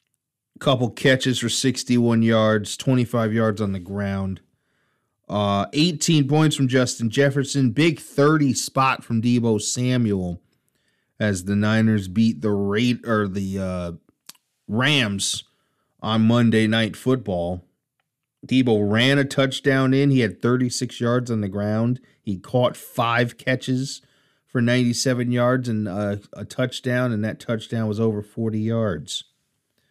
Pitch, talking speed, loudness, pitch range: 120 Hz, 130 wpm, -21 LUFS, 105-130 Hz